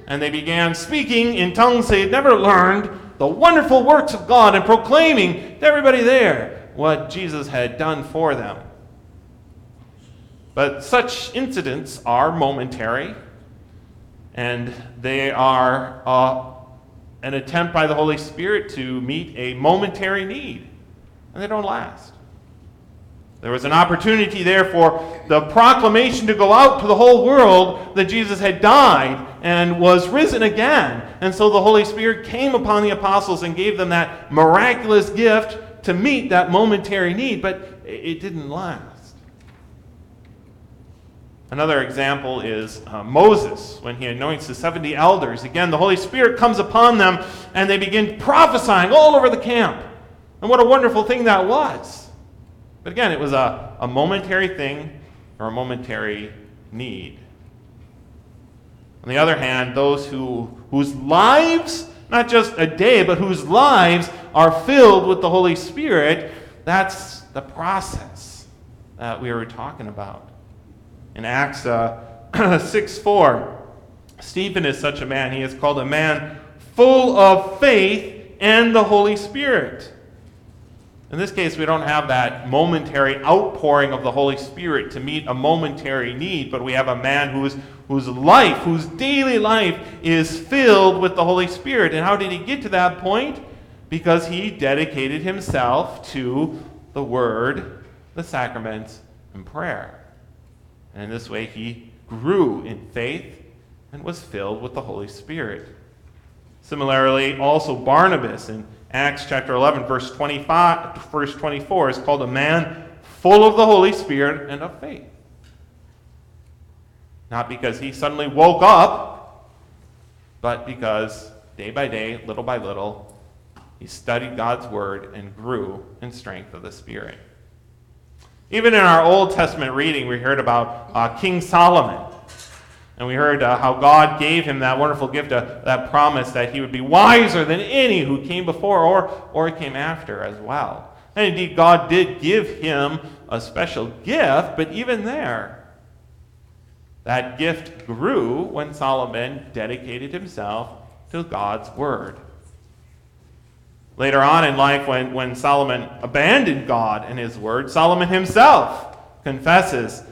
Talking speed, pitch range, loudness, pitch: 145 wpm, 125-190 Hz, -17 LUFS, 150 Hz